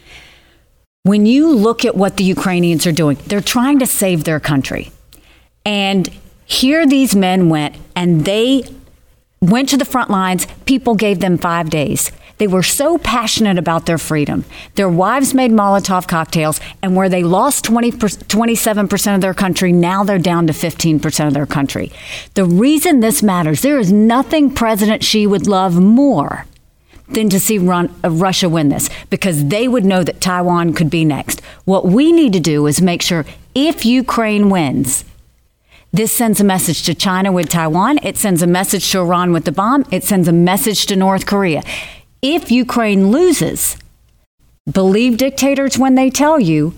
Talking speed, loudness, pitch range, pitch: 170 wpm, -13 LUFS, 170-230 Hz, 195 Hz